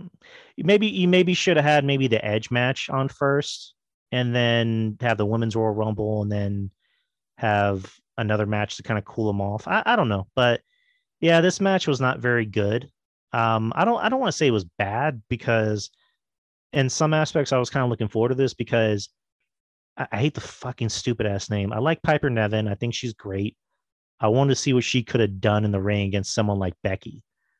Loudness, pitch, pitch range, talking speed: -23 LUFS, 115 Hz, 105-140 Hz, 215 wpm